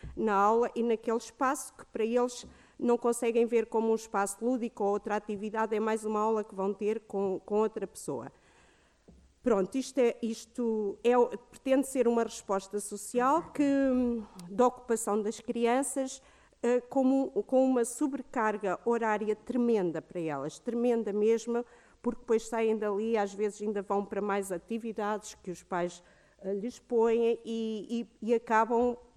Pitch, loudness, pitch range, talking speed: 225 Hz, -31 LUFS, 210-240 Hz, 150 wpm